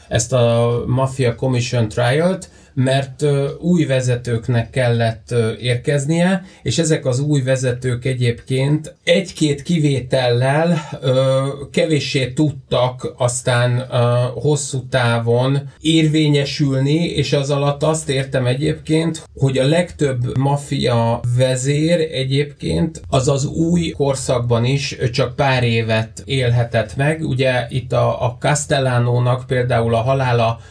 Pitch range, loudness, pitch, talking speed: 125-150 Hz, -18 LUFS, 135 Hz, 110 wpm